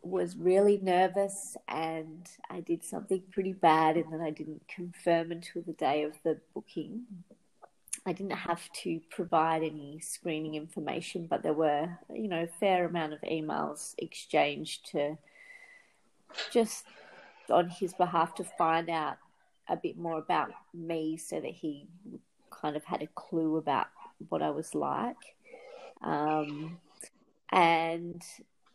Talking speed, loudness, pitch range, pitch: 140 wpm, -32 LUFS, 160-190 Hz, 170 Hz